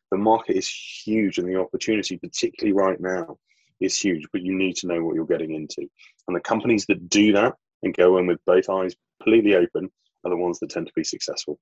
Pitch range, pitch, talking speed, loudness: 90-110 Hz, 95 Hz, 220 wpm, -23 LUFS